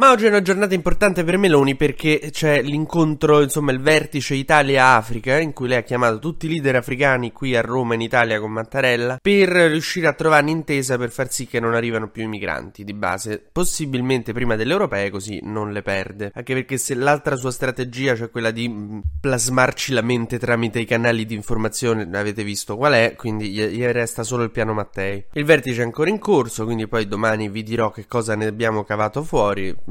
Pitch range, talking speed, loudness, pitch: 110-145 Hz, 200 wpm, -19 LUFS, 125 Hz